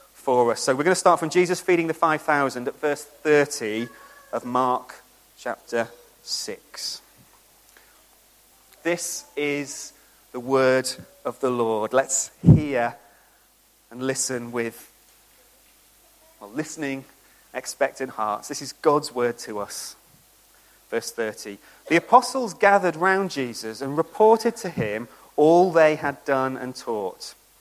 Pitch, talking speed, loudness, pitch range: 140 Hz, 130 wpm, -23 LUFS, 120-165 Hz